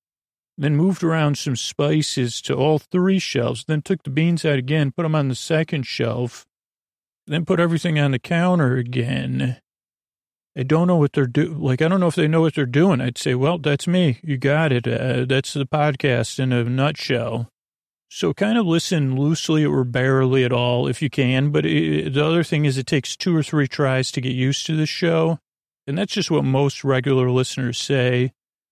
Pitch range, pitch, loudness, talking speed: 130-160 Hz, 140 Hz, -20 LUFS, 205 wpm